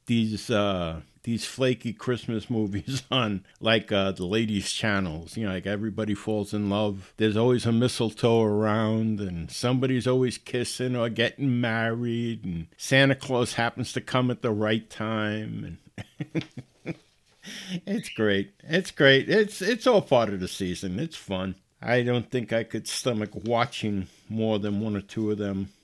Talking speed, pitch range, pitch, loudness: 160 wpm, 105-125 Hz, 110 Hz, -26 LUFS